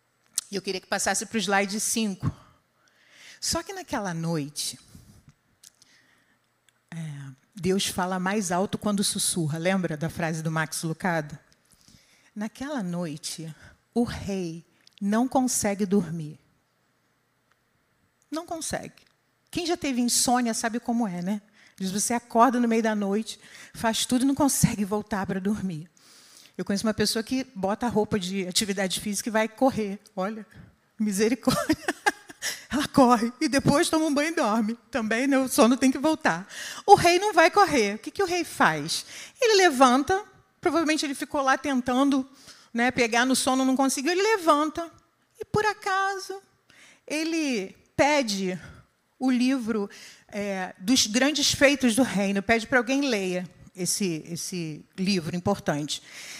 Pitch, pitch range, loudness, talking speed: 220 Hz, 190-275 Hz, -25 LUFS, 145 wpm